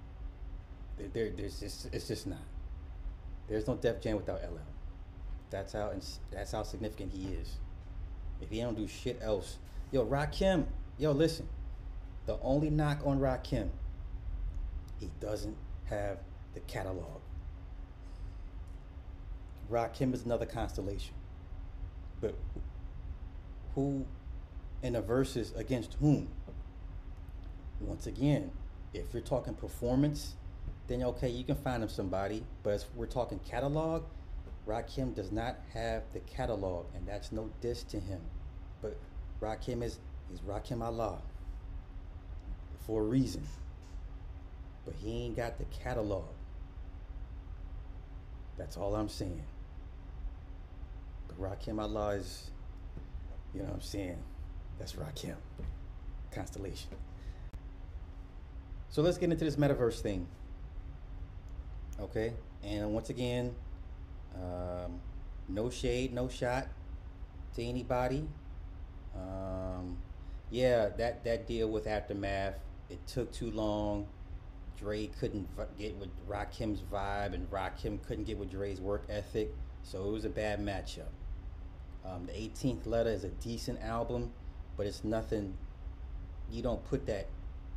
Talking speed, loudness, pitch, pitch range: 120 wpm, -38 LUFS, 95 Hz, 75-110 Hz